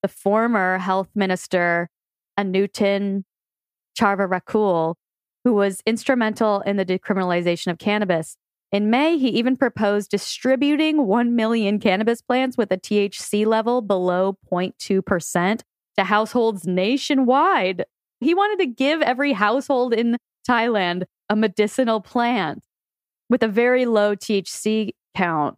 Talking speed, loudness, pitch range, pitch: 115 wpm, -21 LUFS, 190-240 Hz, 210 Hz